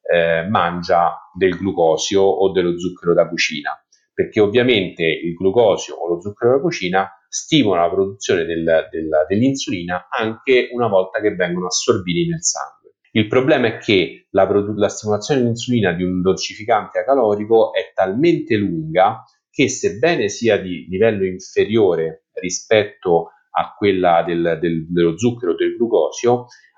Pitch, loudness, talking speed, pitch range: 95 Hz, -18 LUFS, 145 wpm, 85-120 Hz